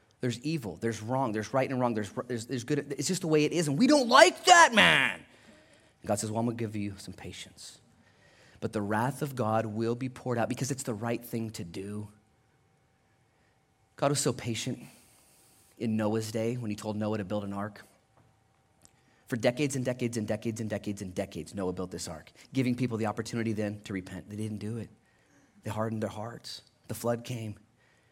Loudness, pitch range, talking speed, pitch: -29 LUFS, 105-125 Hz, 205 wpm, 115 Hz